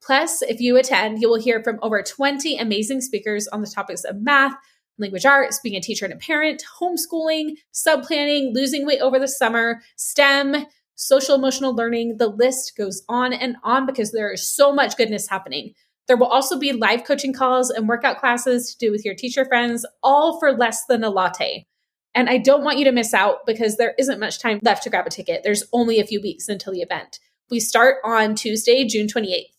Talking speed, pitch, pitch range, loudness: 210 wpm, 250 Hz, 220-275 Hz, -19 LUFS